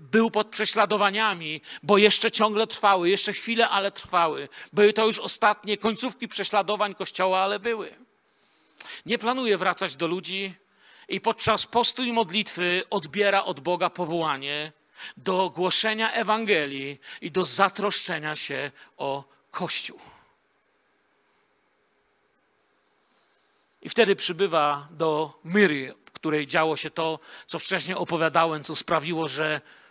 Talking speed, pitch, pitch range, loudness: 120 wpm, 190 Hz, 160-215 Hz, -23 LUFS